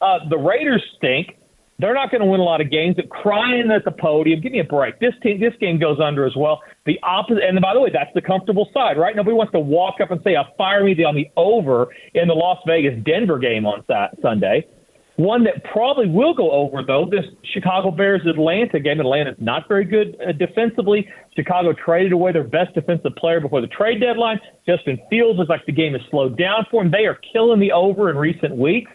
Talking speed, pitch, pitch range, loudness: 220 wpm, 180 Hz, 155-210 Hz, -18 LUFS